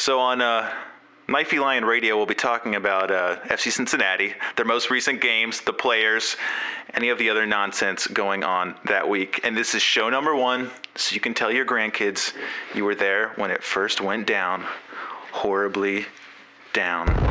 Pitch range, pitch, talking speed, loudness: 100-120 Hz, 110 Hz, 175 wpm, -22 LUFS